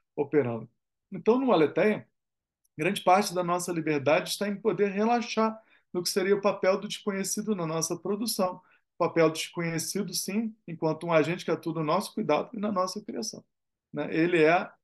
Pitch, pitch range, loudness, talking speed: 185 Hz, 160-205 Hz, -28 LUFS, 175 wpm